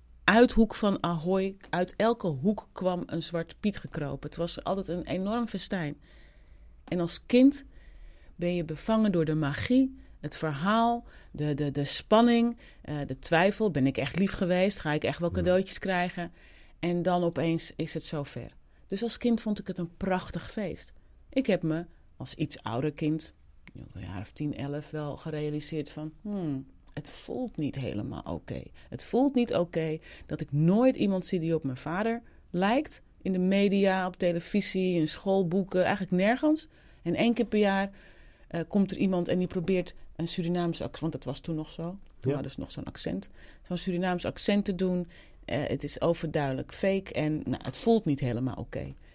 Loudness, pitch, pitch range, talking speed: -29 LUFS, 175 Hz, 150-195 Hz, 185 wpm